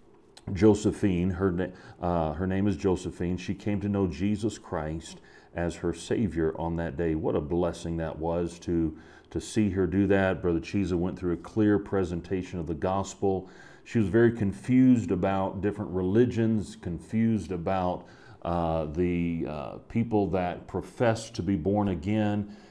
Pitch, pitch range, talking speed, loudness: 95 Hz, 85-105 Hz, 155 wpm, -28 LUFS